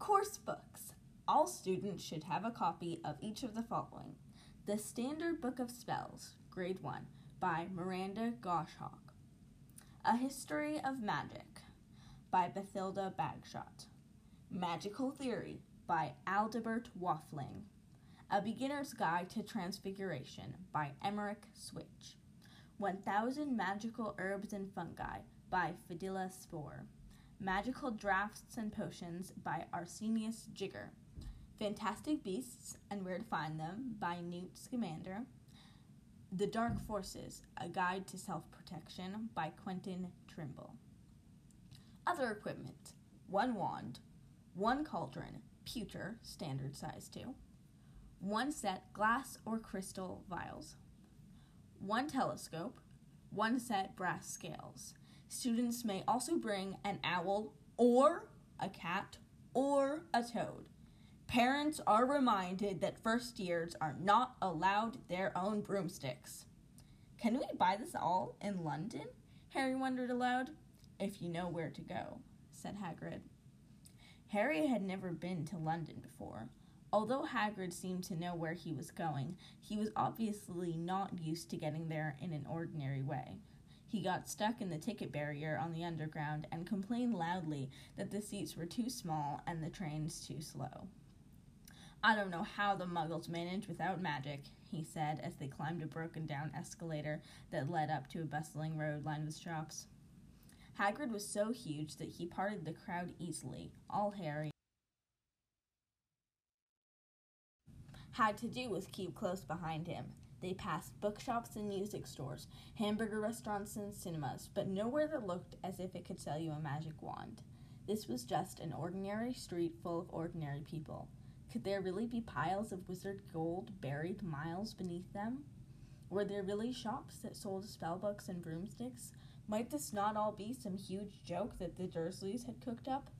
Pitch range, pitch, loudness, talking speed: 160-215 Hz, 190 Hz, -41 LUFS, 140 wpm